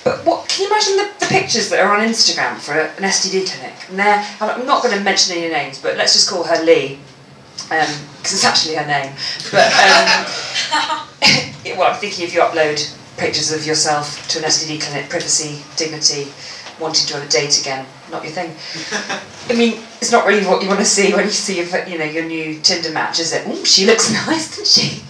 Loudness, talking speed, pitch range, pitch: -15 LUFS, 220 wpm, 155-200 Hz, 170 Hz